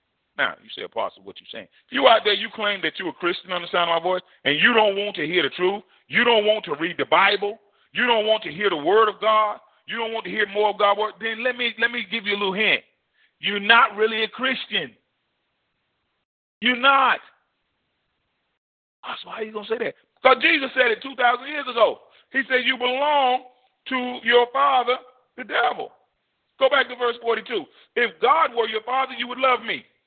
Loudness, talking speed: -21 LUFS, 220 wpm